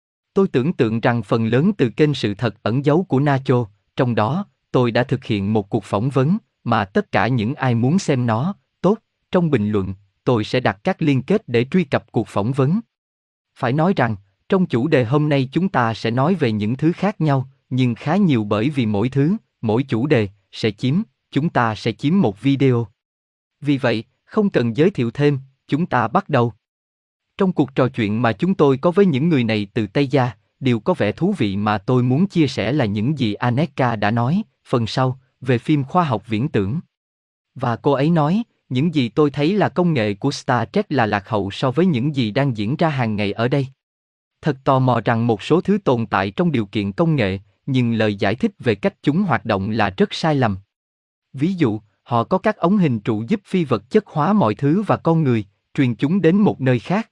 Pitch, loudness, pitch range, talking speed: 130 Hz, -19 LUFS, 110-155 Hz, 225 wpm